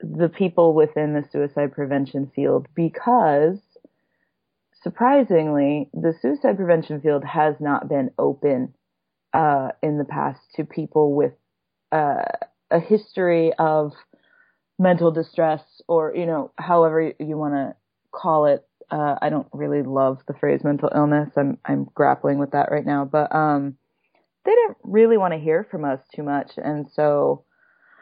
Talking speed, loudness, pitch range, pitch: 150 wpm, -21 LUFS, 145-175 Hz, 155 Hz